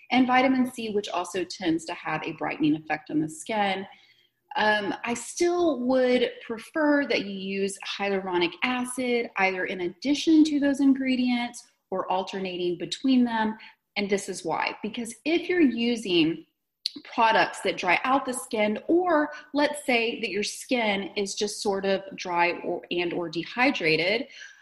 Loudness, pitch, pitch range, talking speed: -26 LUFS, 230 Hz, 190-260 Hz, 150 wpm